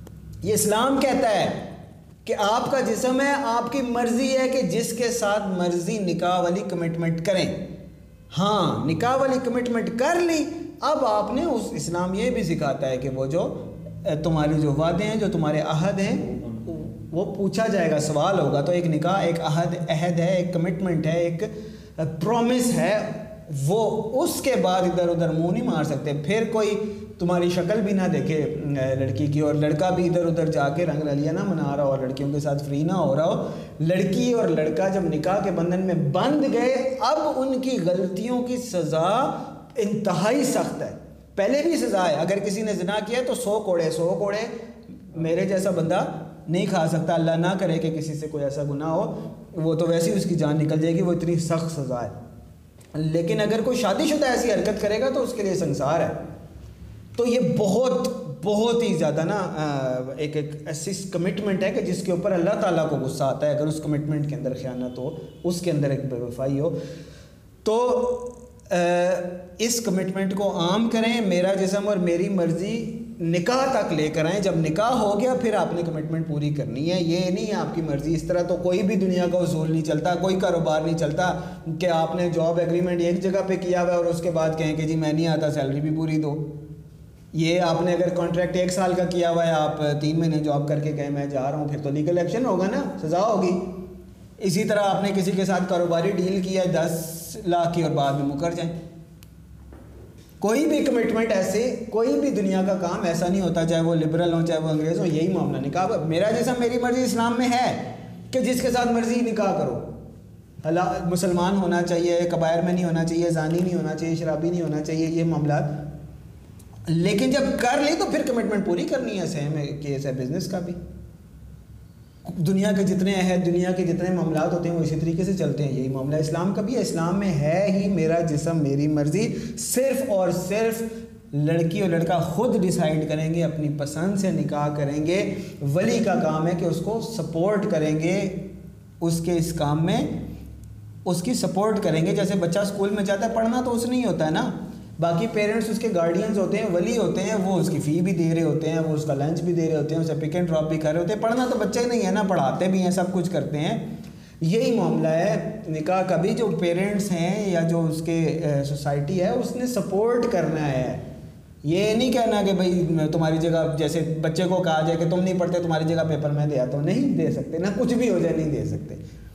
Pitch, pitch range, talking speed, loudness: 175 Hz, 160-205 Hz, 210 wpm, -23 LUFS